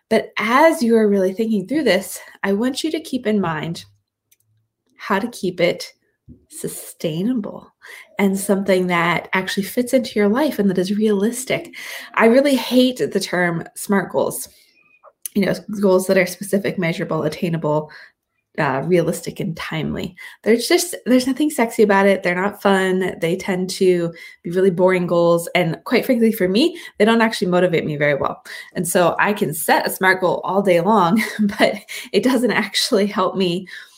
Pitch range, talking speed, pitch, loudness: 180-225 Hz, 170 wpm, 195 Hz, -18 LUFS